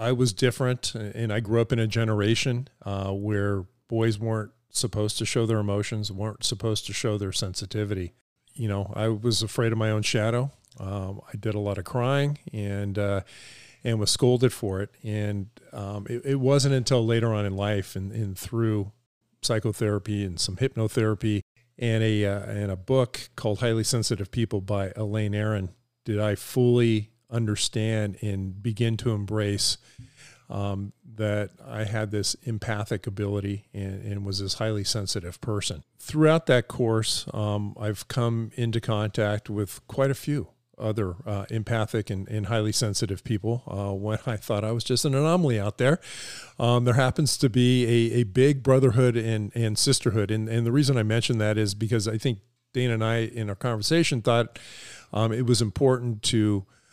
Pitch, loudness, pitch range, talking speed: 110 Hz, -26 LUFS, 105-120 Hz, 175 wpm